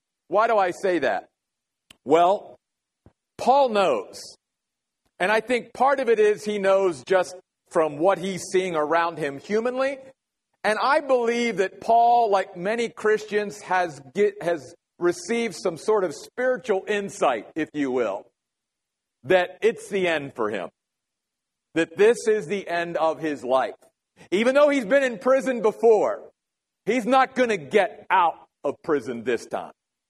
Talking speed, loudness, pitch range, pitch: 150 wpm, -23 LUFS, 180-235 Hz, 205 Hz